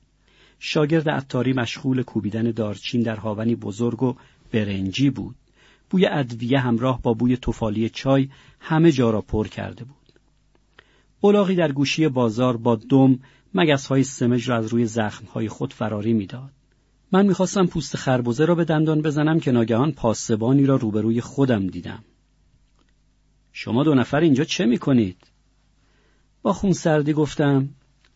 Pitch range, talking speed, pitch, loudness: 115-150 Hz, 145 wpm, 130 Hz, -21 LUFS